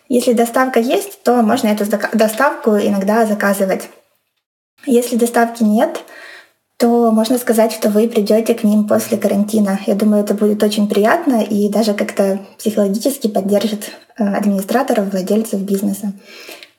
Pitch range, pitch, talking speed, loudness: 205-235 Hz, 215 Hz, 130 wpm, -15 LUFS